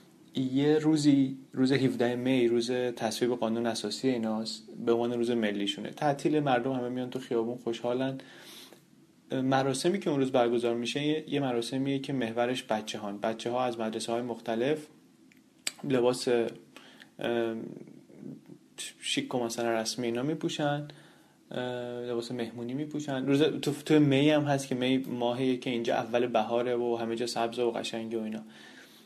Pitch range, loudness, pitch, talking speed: 115-135 Hz, -30 LUFS, 125 Hz, 145 wpm